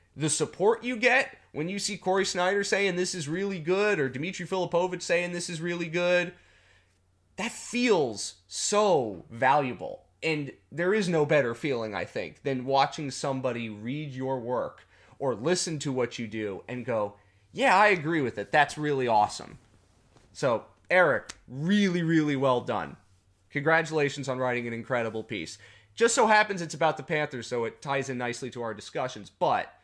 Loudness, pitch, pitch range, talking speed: -27 LUFS, 145 Hz, 120-175 Hz, 170 wpm